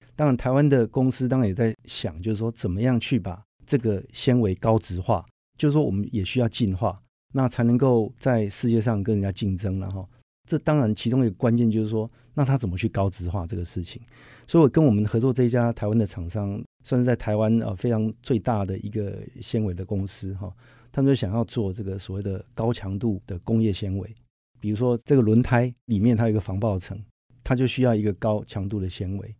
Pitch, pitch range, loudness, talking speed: 115 Hz, 100-125 Hz, -24 LUFS, 325 characters per minute